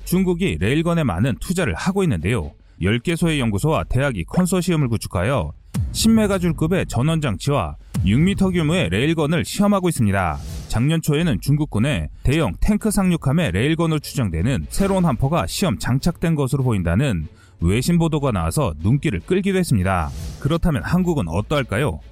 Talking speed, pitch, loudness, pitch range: 370 characters per minute, 145 Hz, -20 LUFS, 110-175 Hz